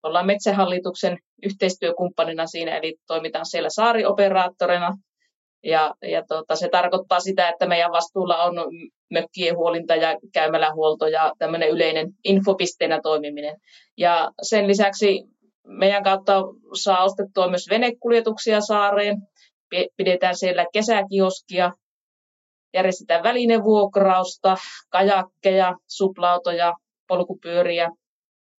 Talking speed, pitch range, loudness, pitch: 95 wpm, 170-200 Hz, -21 LUFS, 180 Hz